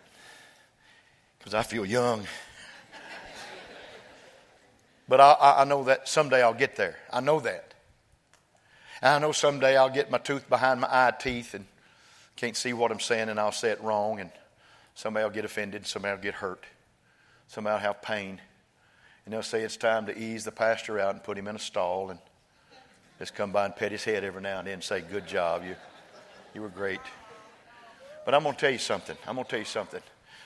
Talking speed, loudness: 200 wpm, -27 LUFS